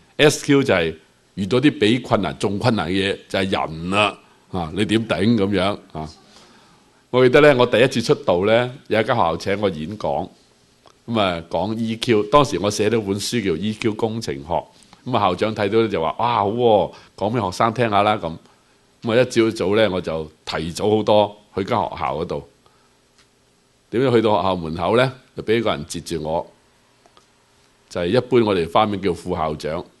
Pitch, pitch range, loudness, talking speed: 105 Hz, 90-115 Hz, -20 LUFS, 280 characters per minute